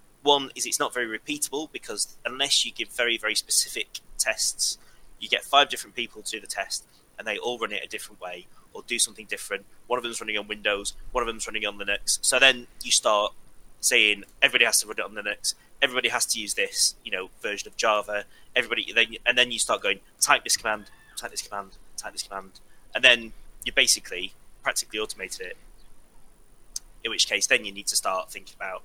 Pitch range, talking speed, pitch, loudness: 100-130 Hz, 210 wpm, 115 Hz, -24 LUFS